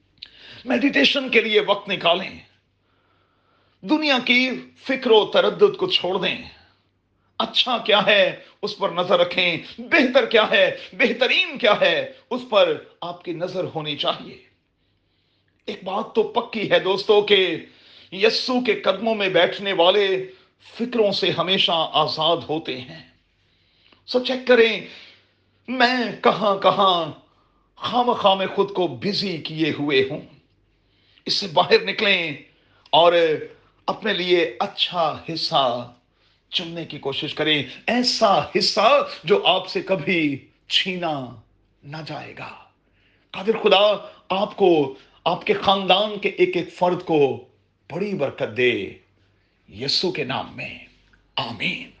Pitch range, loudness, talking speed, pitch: 145-220 Hz, -20 LUFS, 125 wpm, 185 Hz